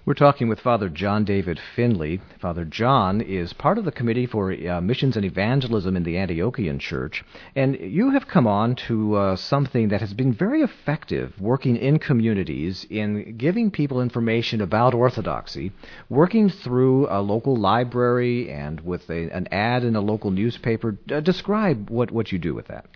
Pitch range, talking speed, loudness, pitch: 100-135 Hz, 175 wpm, -22 LUFS, 115 Hz